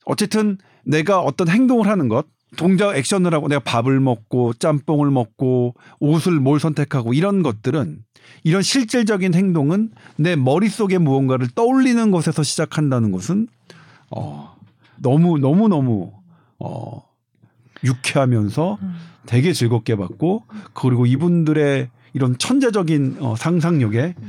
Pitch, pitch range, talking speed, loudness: 150 Hz, 125-180 Hz, 280 characters per minute, -18 LUFS